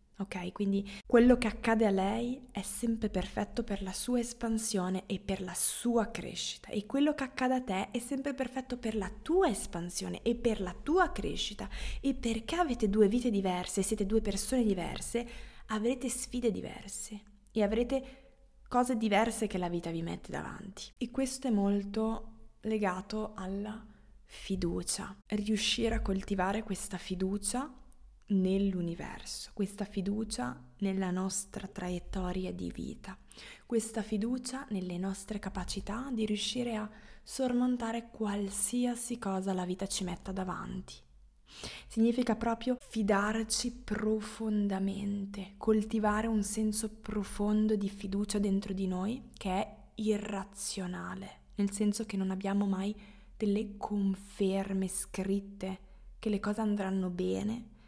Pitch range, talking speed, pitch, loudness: 195-230 Hz, 130 wpm, 210 Hz, -34 LUFS